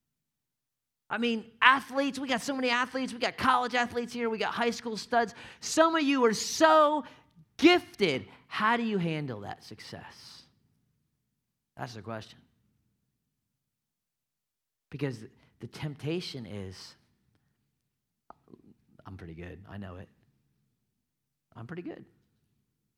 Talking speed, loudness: 120 wpm, -28 LUFS